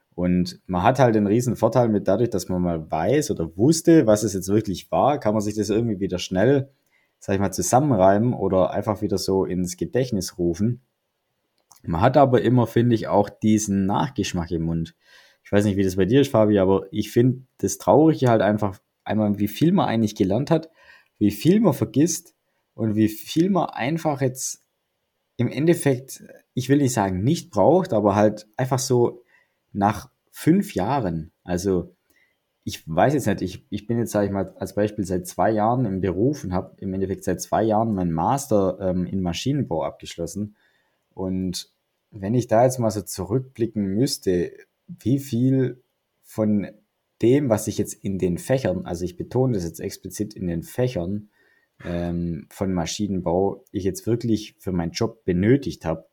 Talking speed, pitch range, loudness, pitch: 180 wpm, 95-125 Hz, -22 LUFS, 105 Hz